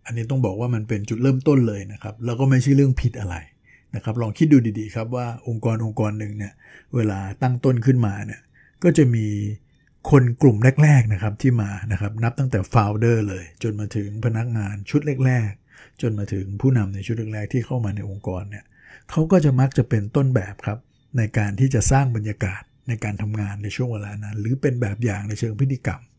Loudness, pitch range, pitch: -21 LUFS, 105-130 Hz, 115 Hz